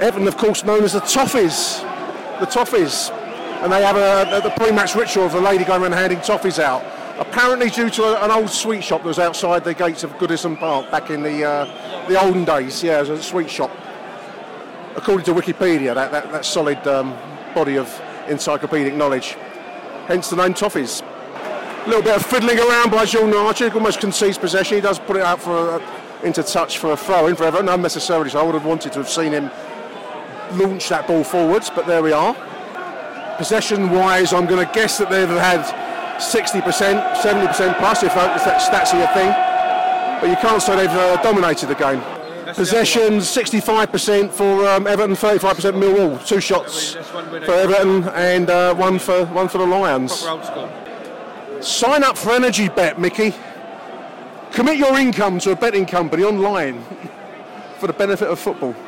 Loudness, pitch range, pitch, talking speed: -17 LUFS, 170-215 Hz, 190 Hz, 180 wpm